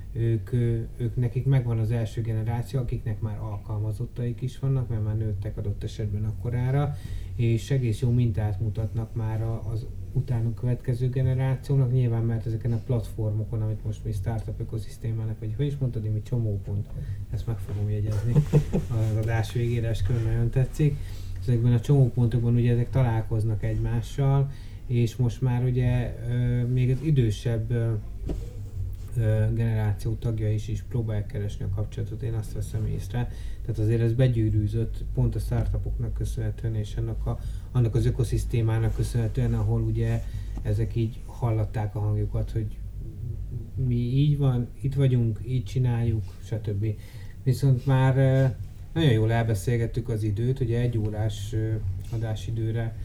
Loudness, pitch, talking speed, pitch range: -27 LUFS, 115 Hz, 140 wpm, 110-120 Hz